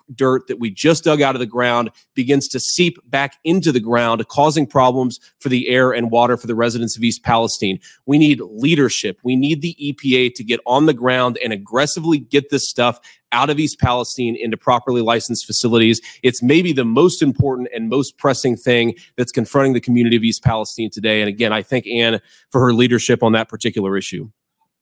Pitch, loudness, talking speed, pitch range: 125 Hz, -16 LUFS, 200 wpm, 115-140 Hz